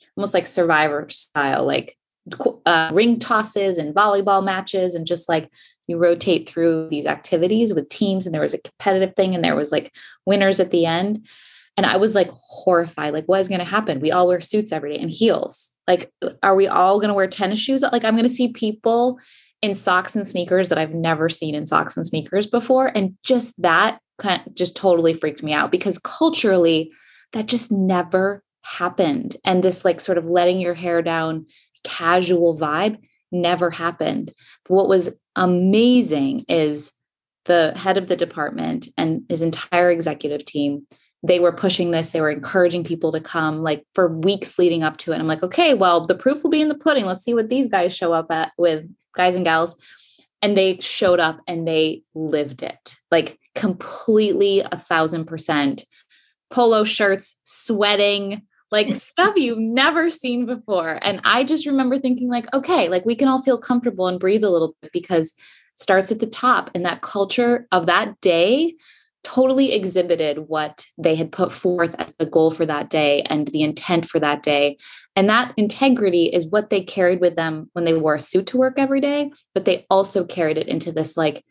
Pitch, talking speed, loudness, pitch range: 185 Hz, 195 wpm, -19 LUFS, 165-220 Hz